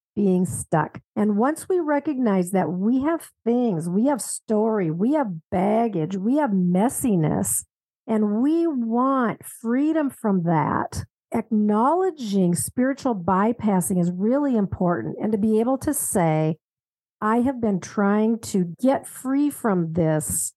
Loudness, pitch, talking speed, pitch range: -22 LUFS, 215 Hz, 135 wpm, 185-260 Hz